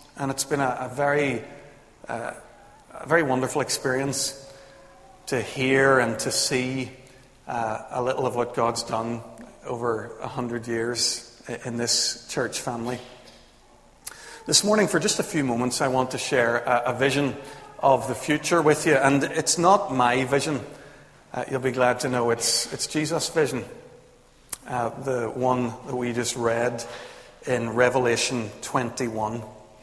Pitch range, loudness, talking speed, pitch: 120-135 Hz, -24 LUFS, 150 wpm, 125 Hz